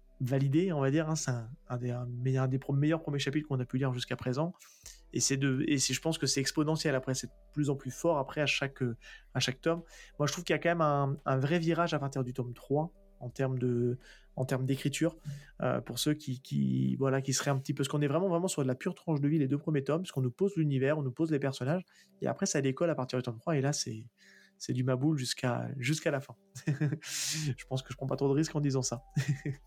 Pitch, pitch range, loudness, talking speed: 140 Hz, 130-155 Hz, -32 LUFS, 275 wpm